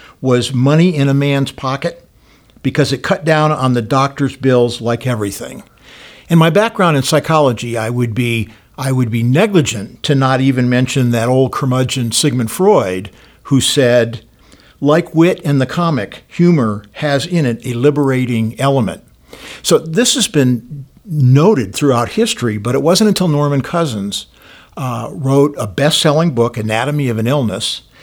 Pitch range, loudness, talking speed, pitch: 120-150 Hz, -14 LUFS, 155 wpm, 135 Hz